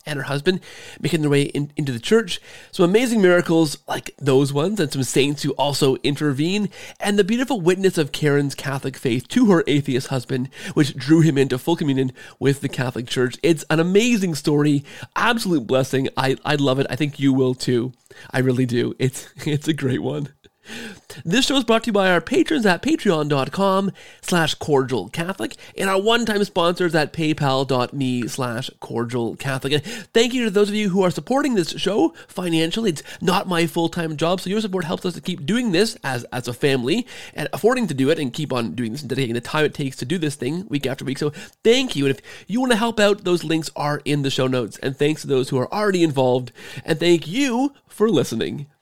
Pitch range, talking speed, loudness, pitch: 135-190 Hz, 210 wpm, -21 LUFS, 155 Hz